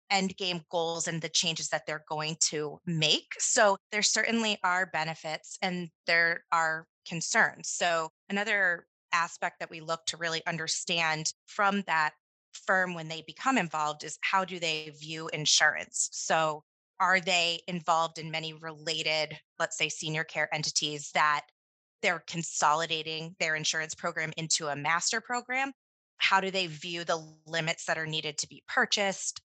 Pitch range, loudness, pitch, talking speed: 155-185 Hz, -29 LUFS, 165 Hz, 155 wpm